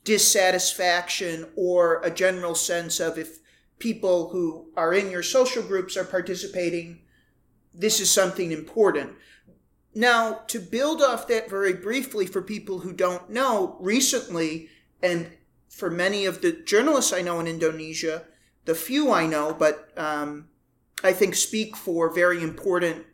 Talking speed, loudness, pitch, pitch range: 145 wpm, -24 LUFS, 185 Hz, 165-210 Hz